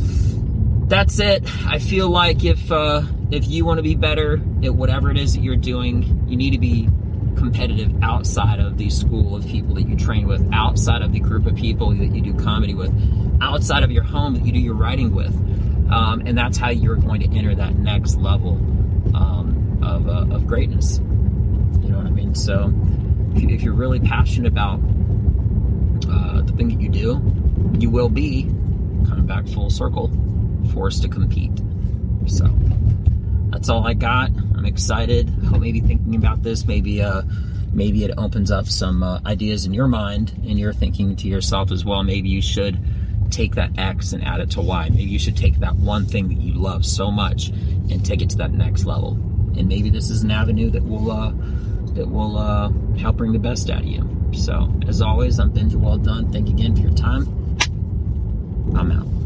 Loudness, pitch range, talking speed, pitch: -19 LUFS, 95-105 Hz, 195 wpm, 100 Hz